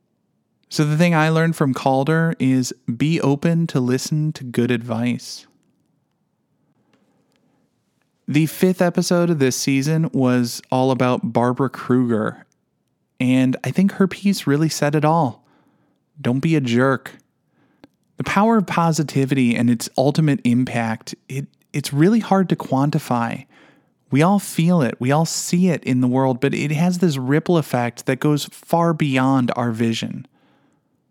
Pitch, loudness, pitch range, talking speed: 140 Hz, -19 LUFS, 130-165 Hz, 145 wpm